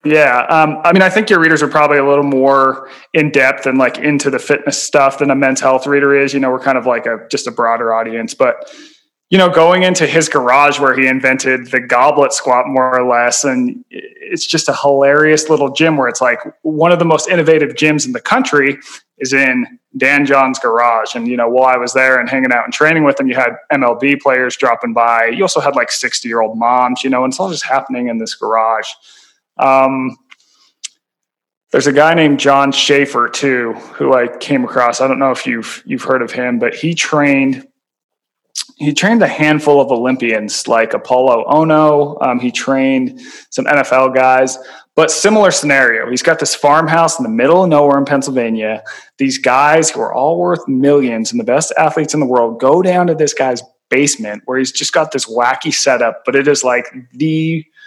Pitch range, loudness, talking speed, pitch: 130-155 Hz, -12 LUFS, 205 wpm, 140 Hz